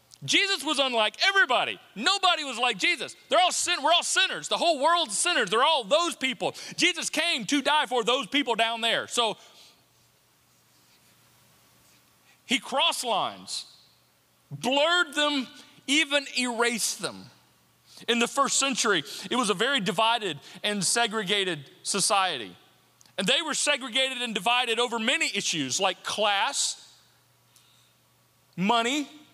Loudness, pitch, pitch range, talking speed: -25 LUFS, 265 Hz, 230-310 Hz, 130 wpm